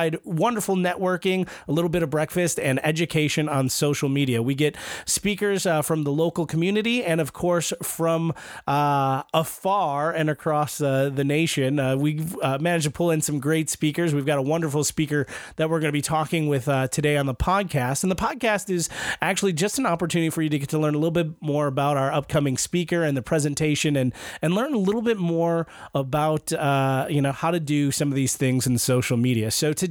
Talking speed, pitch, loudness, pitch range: 215 wpm, 155 Hz, -23 LUFS, 145-170 Hz